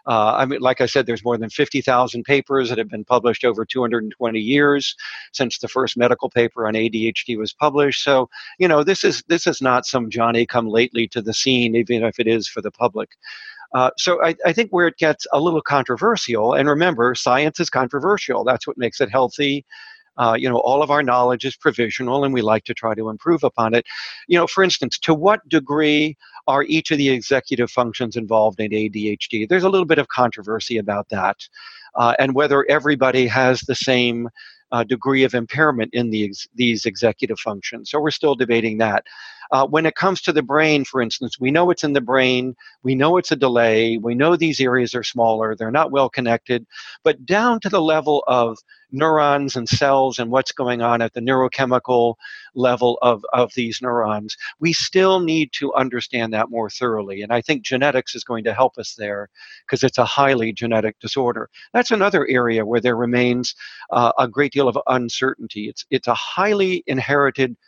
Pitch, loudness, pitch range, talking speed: 125 Hz, -19 LUFS, 115-145 Hz, 205 wpm